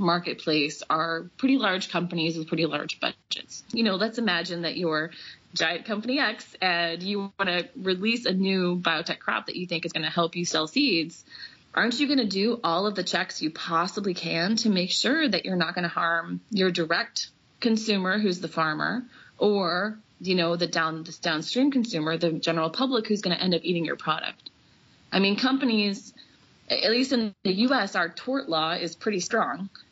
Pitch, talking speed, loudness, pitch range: 185 Hz, 195 wpm, -26 LUFS, 165-220 Hz